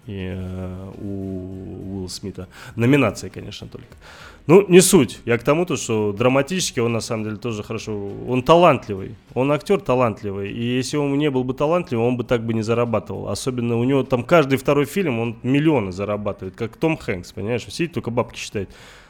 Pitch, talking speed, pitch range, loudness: 120 Hz, 180 wpm, 100-140 Hz, -20 LUFS